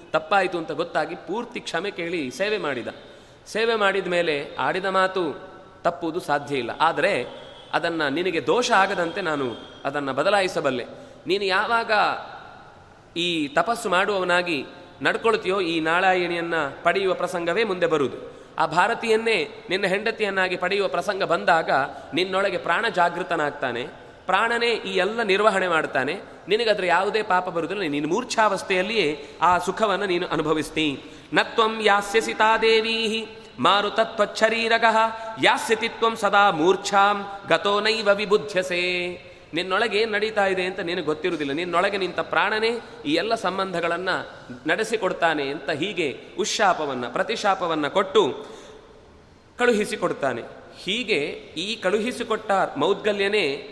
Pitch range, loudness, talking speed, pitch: 175-220 Hz, -23 LUFS, 105 wpm, 195 Hz